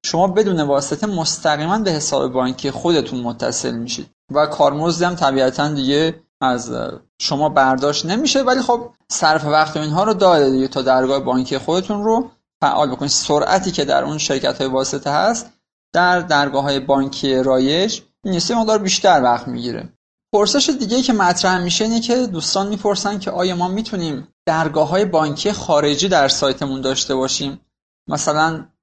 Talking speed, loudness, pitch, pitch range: 155 wpm, -17 LUFS, 155 Hz, 140-195 Hz